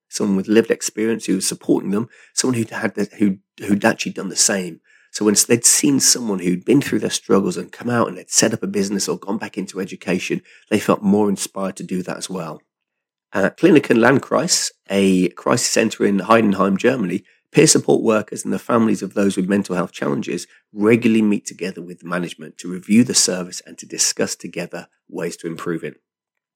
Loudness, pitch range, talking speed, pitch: -18 LUFS, 95-110 Hz, 205 wpm, 100 Hz